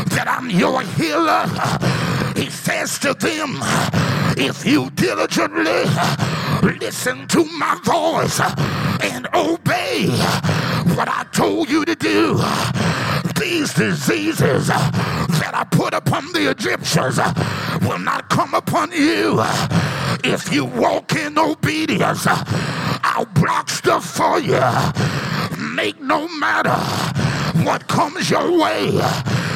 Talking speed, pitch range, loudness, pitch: 110 wpm, 280-335 Hz, -18 LUFS, 315 Hz